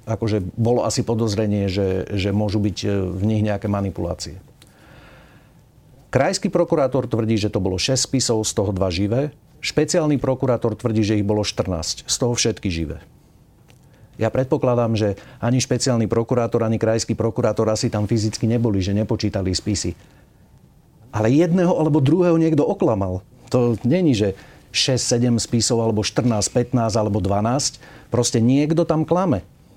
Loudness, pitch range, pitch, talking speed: -20 LUFS, 105-130 Hz, 115 Hz, 145 wpm